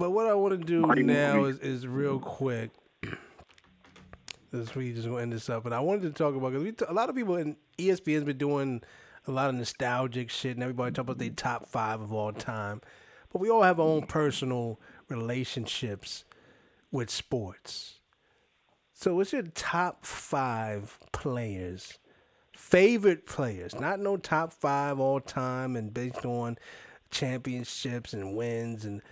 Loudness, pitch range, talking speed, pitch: -30 LUFS, 115-150 Hz, 165 wpm, 130 Hz